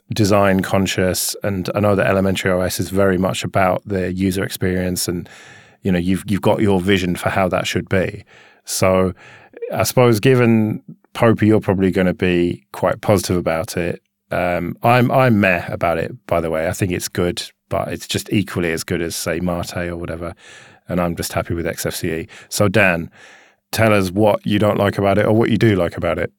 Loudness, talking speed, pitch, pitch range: -18 LUFS, 200 wpm, 95 Hz, 90-105 Hz